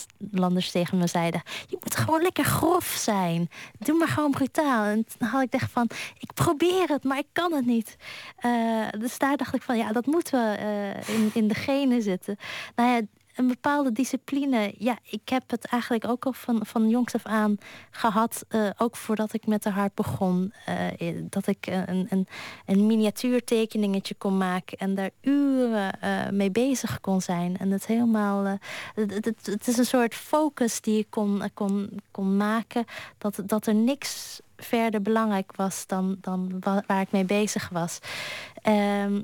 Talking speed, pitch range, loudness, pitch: 180 wpm, 200-245 Hz, -26 LUFS, 220 Hz